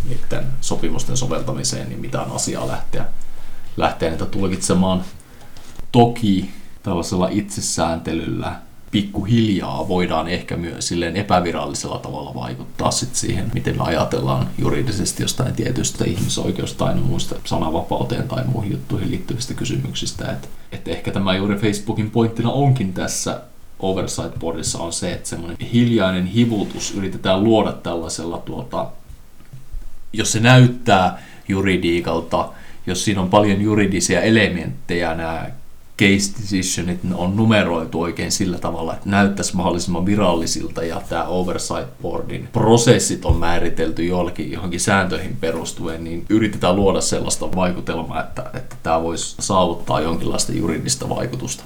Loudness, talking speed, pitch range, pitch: -20 LUFS, 120 wpm, 80-105 Hz, 90 Hz